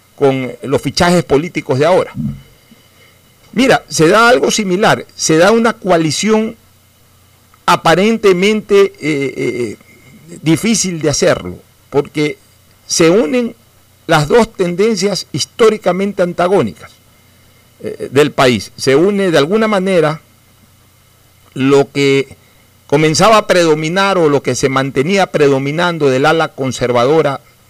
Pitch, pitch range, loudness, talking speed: 145 Hz, 120-185 Hz, -12 LUFS, 110 wpm